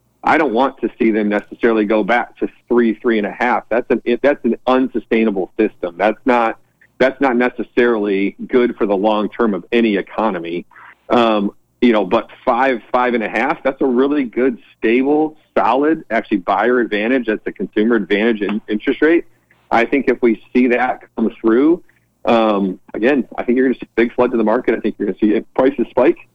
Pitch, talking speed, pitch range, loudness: 120 Hz, 205 wpm, 110-130 Hz, -16 LUFS